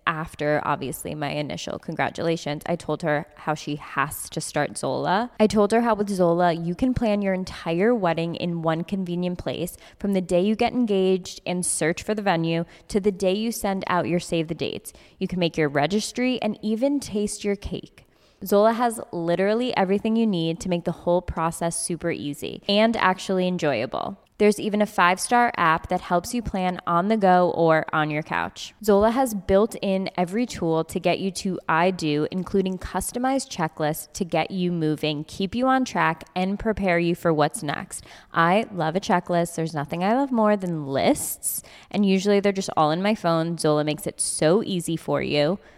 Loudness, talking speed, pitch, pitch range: -24 LUFS, 195 wpm, 180 Hz, 165-205 Hz